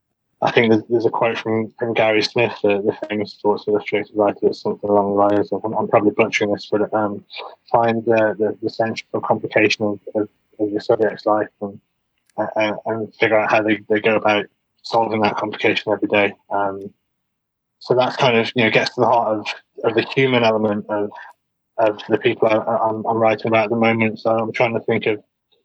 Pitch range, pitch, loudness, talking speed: 105-115 Hz, 110 Hz, -19 LUFS, 210 wpm